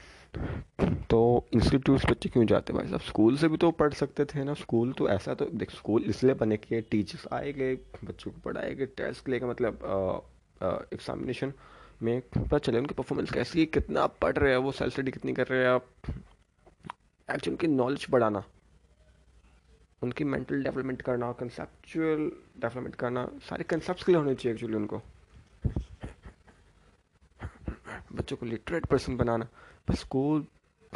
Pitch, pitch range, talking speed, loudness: 120 Hz, 105-140 Hz, 150 wpm, -30 LUFS